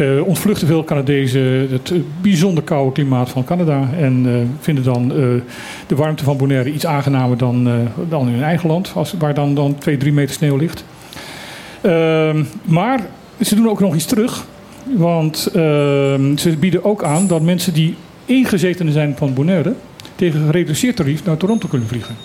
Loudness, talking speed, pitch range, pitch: -16 LUFS, 170 wpm, 140-175 Hz, 155 Hz